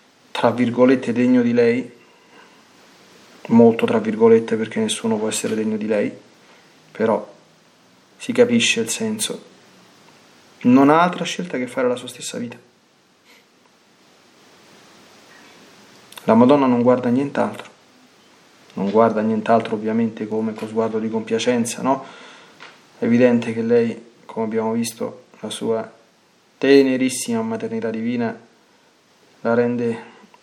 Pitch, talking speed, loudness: 130 Hz, 115 wpm, -19 LUFS